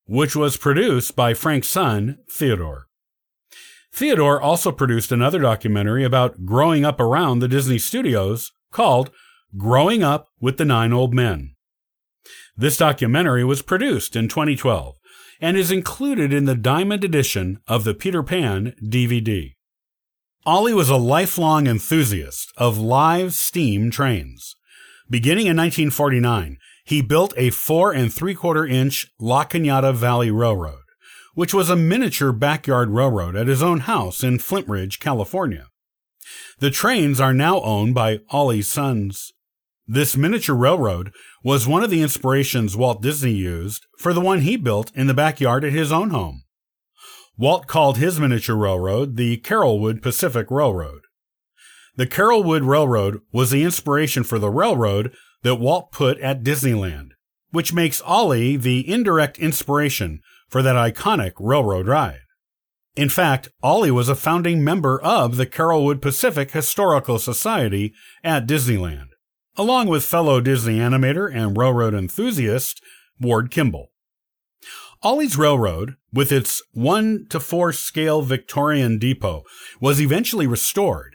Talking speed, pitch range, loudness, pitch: 135 wpm, 115-155 Hz, -19 LUFS, 130 Hz